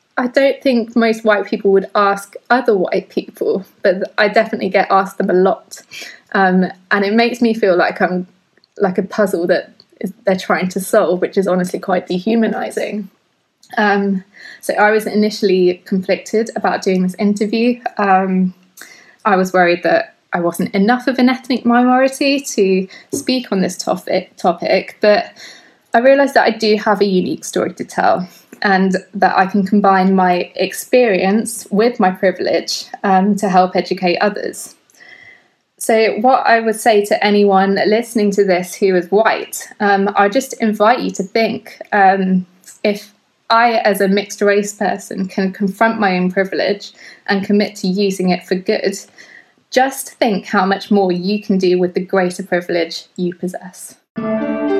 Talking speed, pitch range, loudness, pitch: 165 wpm, 190-225 Hz, -15 LUFS, 200 Hz